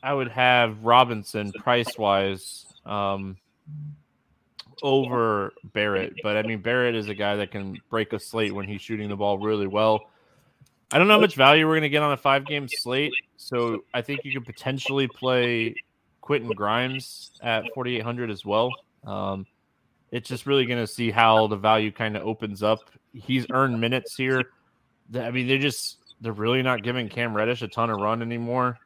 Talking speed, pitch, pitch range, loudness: 185 wpm, 120 Hz, 110-130 Hz, -24 LUFS